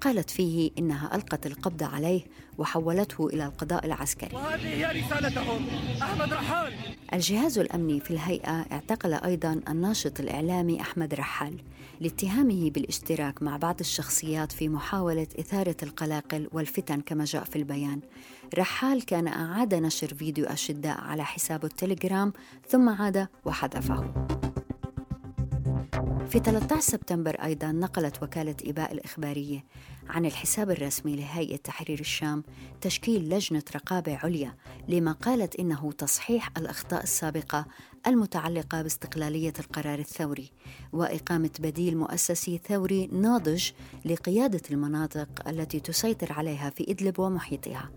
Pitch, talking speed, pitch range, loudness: 160 Hz, 110 wpm, 150-180 Hz, -29 LUFS